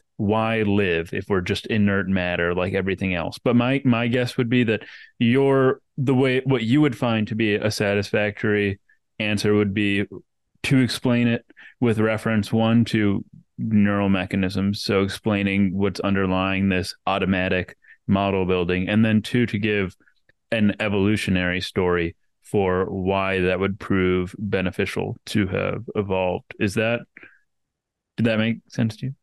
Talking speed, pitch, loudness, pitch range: 150 wpm, 105 Hz, -22 LUFS, 95-115 Hz